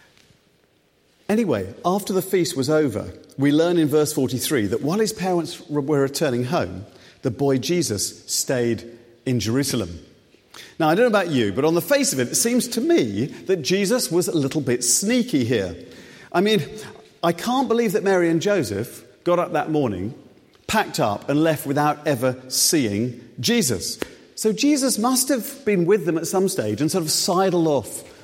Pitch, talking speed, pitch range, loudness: 160 Hz, 180 wpm, 130-205 Hz, -21 LUFS